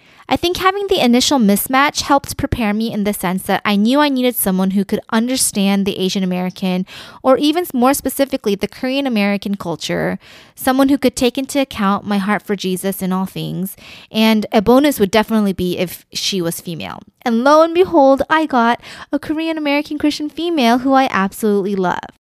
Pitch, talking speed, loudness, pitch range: 225 Hz, 190 wpm, -16 LUFS, 195-275 Hz